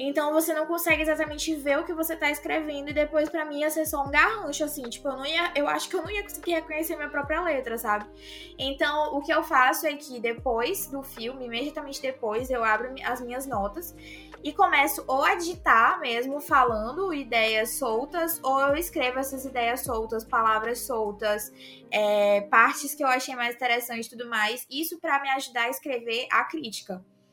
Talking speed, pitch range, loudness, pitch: 200 wpm, 235-310 Hz, -26 LUFS, 275 Hz